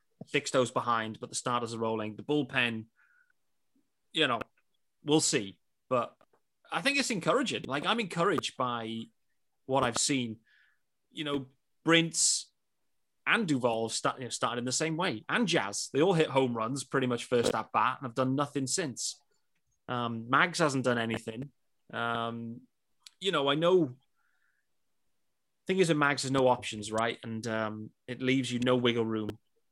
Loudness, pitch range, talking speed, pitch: -30 LUFS, 115-150 Hz, 165 wpm, 130 Hz